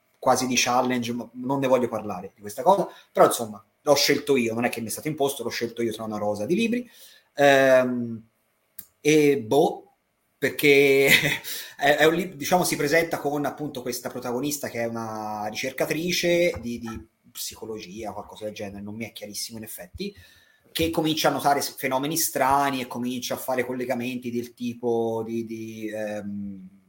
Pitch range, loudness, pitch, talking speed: 110-145 Hz, -24 LUFS, 125 Hz, 170 wpm